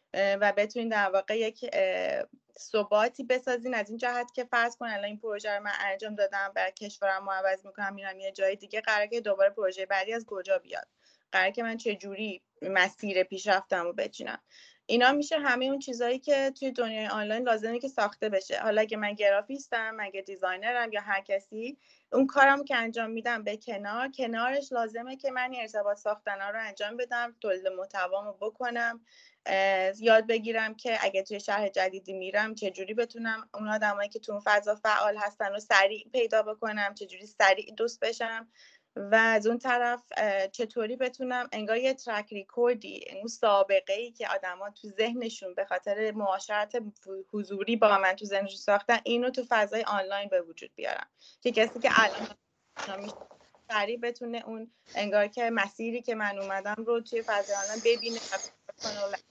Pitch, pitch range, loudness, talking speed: 215 Hz, 200-235 Hz, -29 LUFS, 165 wpm